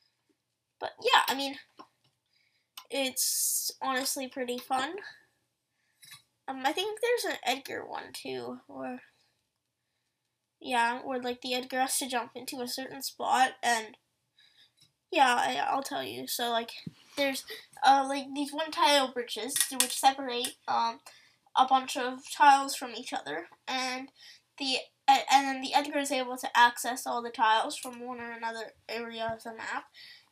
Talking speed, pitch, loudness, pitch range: 150 wpm, 260 Hz, -29 LUFS, 235-275 Hz